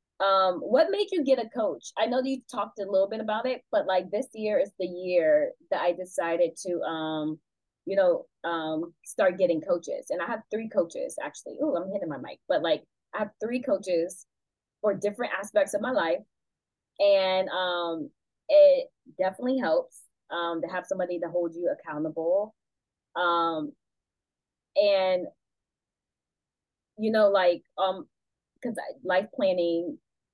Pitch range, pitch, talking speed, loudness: 175-240 Hz, 190 Hz, 160 wpm, -27 LUFS